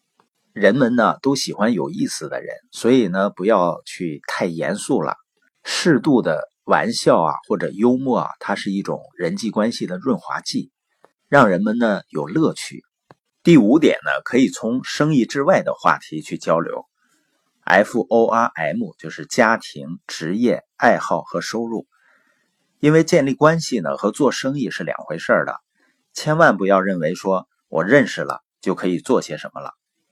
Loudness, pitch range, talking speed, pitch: -19 LUFS, 100-160 Hz, 235 characters per minute, 120 Hz